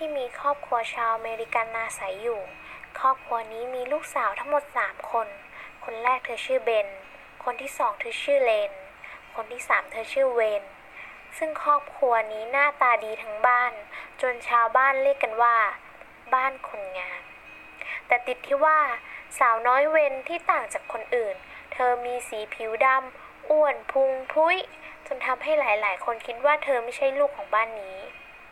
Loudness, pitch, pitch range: -25 LUFS, 255 Hz, 230-290 Hz